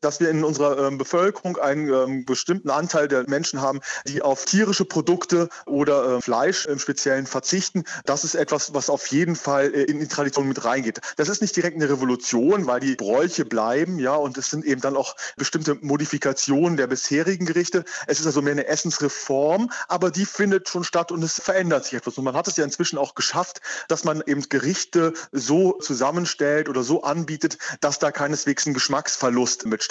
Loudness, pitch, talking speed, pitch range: -22 LUFS, 145 Hz, 195 wpm, 140-170 Hz